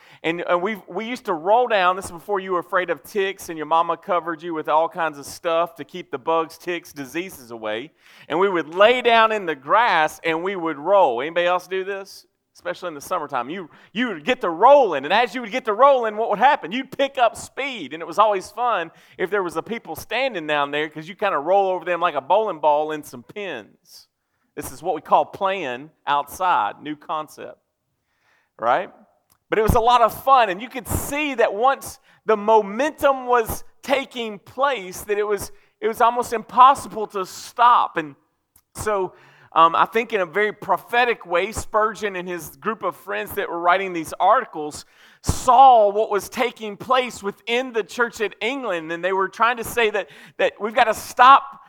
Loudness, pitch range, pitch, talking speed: -20 LUFS, 170-230 Hz, 195 Hz, 210 wpm